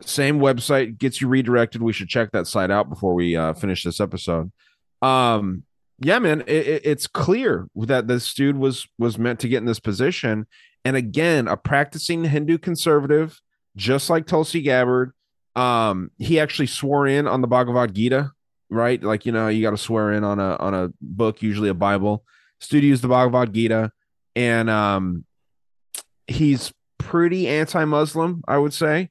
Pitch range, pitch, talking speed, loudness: 105-145 Hz, 125 Hz, 175 wpm, -21 LUFS